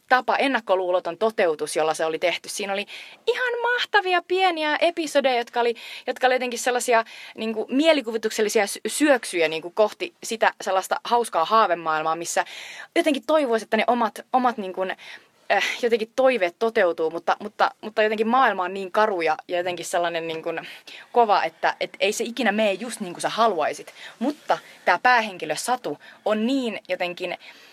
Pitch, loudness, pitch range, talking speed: 220 Hz, -23 LUFS, 180-250 Hz, 160 wpm